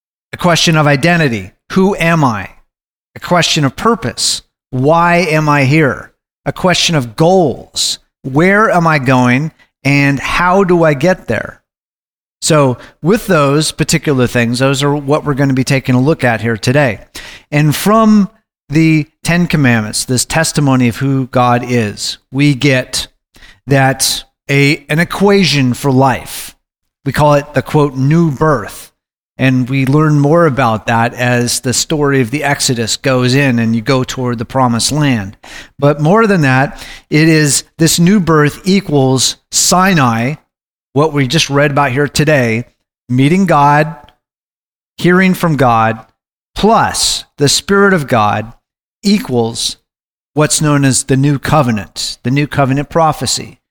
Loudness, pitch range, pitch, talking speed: -11 LUFS, 125-160 Hz, 145 Hz, 150 wpm